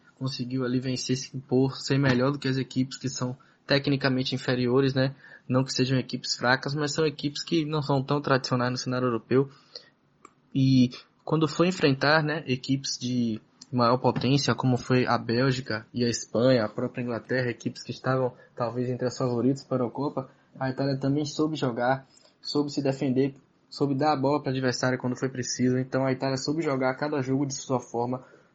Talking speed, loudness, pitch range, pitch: 185 wpm, -27 LUFS, 125-140 Hz, 130 Hz